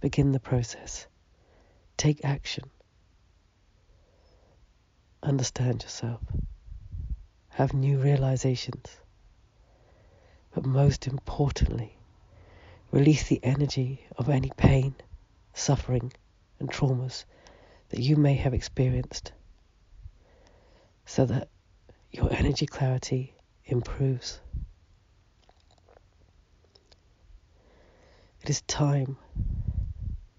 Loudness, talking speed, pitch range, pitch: -28 LUFS, 70 wpm, 90-130 Hz, 105 Hz